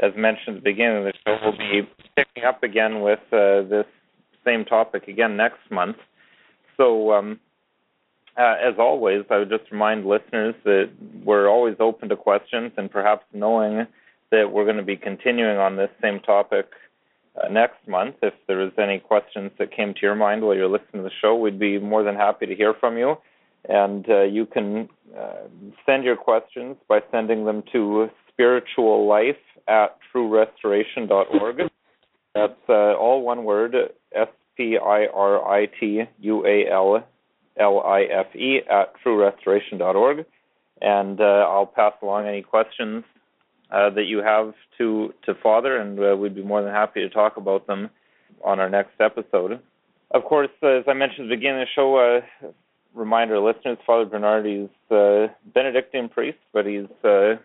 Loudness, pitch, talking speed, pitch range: -21 LUFS, 105 Hz, 165 wpm, 100-115 Hz